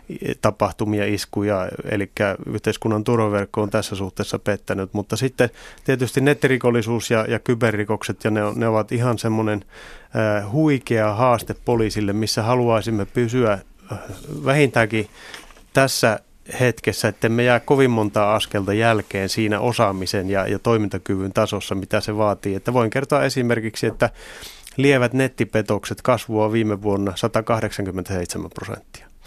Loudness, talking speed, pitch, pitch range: -21 LUFS, 120 wpm, 110 Hz, 105-120 Hz